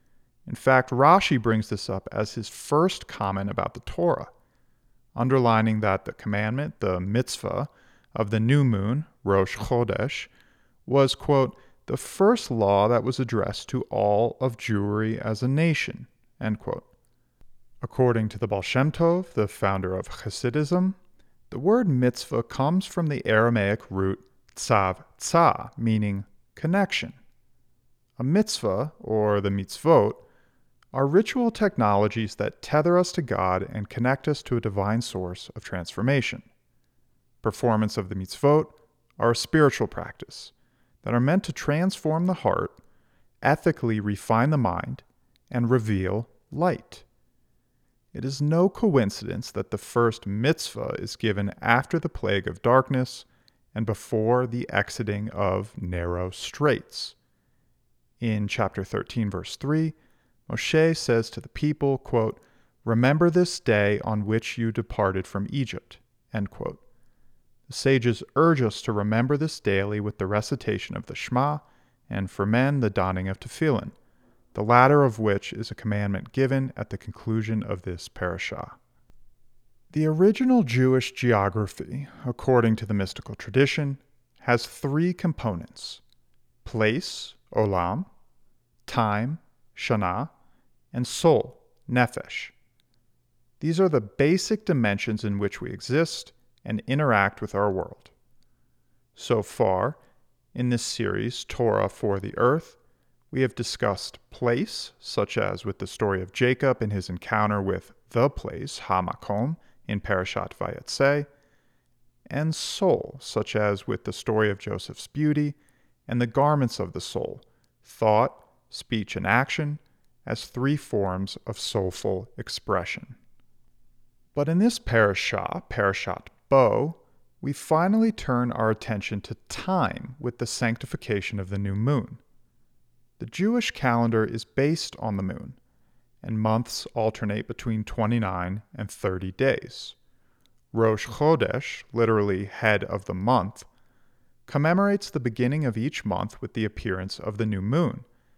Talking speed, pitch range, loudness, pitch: 135 wpm, 105-135 Hz, -25 LUFS, 115 Hz